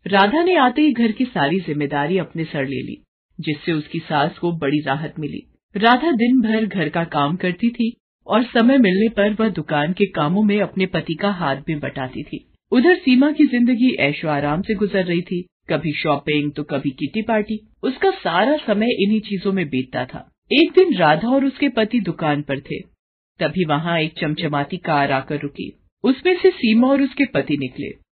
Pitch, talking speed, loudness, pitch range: 185 Hz, 190 wpm, -19 LUFS, 150-235 Hz